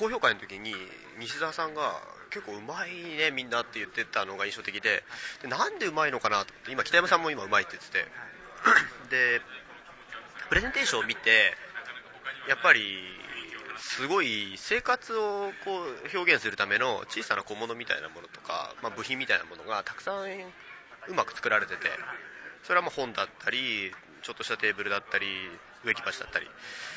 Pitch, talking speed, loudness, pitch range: 195 Hz, 355 characters per minute, -28 LUFS, 155-250 Hz